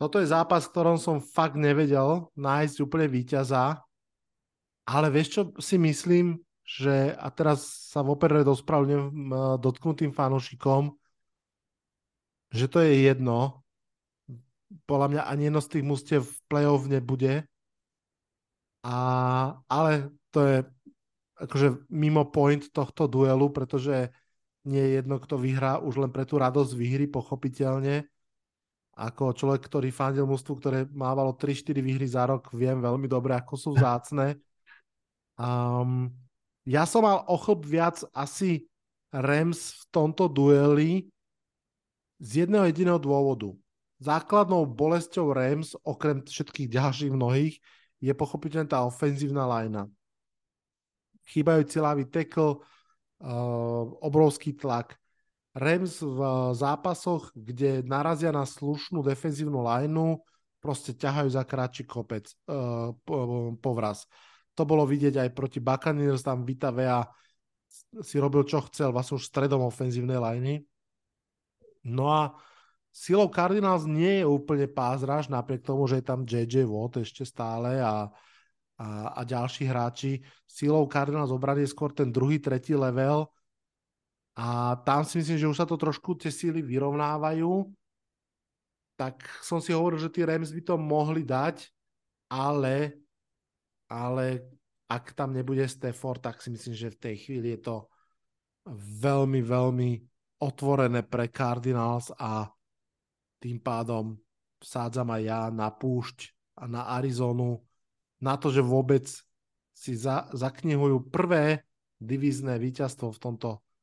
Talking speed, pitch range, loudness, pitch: 125 wpm, 125-150 Hz, -27 LUFS, 135 Hz